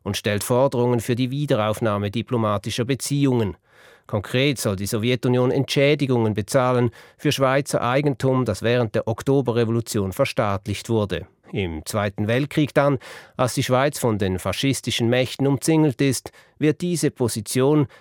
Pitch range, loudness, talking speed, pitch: 110-135 Hz, -22 LUFS, 130 wpm, 125 Hz